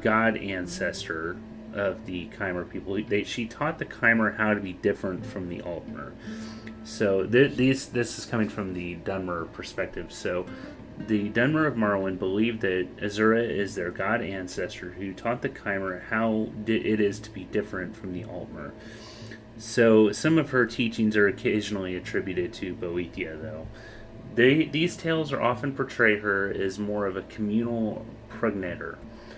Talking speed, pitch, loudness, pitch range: 160 wpm, 110 Hz, -27 LUFS, 95-115 Hz